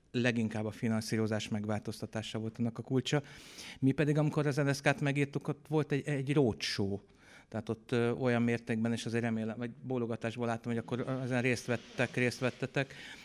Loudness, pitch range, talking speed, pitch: -34 LUFS, 115-140 Hz, 170 wpm, 120 Hz